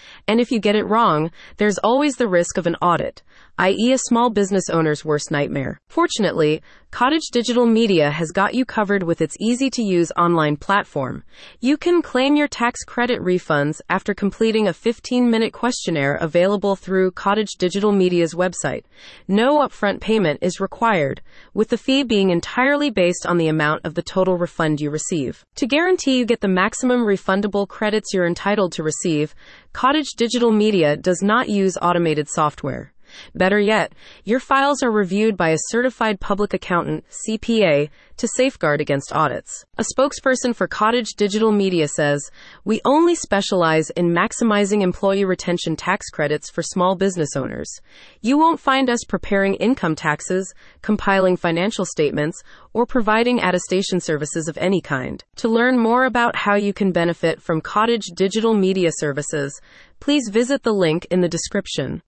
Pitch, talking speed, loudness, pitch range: 195 Hz, 165 wpm, -19 LUFS, 170-235 Hz